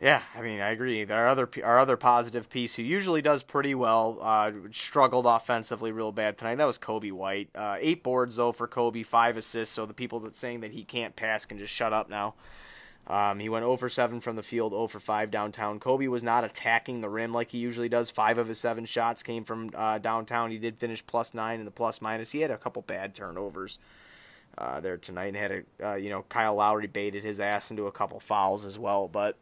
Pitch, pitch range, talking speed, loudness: 115 Hz, 105-120 Hz, 235 wpm, -29 LUFS